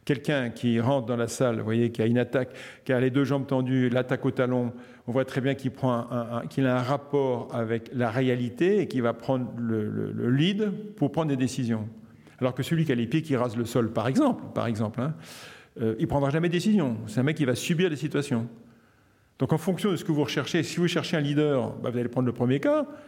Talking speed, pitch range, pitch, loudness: 255 wpm, 120-145 Hz, 130 Hz, -27 LUFS